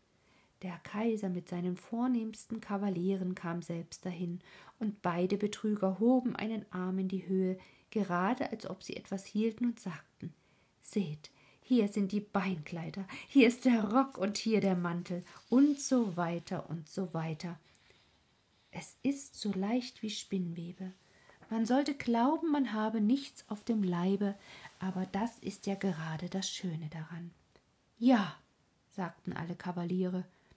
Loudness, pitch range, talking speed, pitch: -34 LUFS, 180-225 Hz, 140 wpm, 195 Hz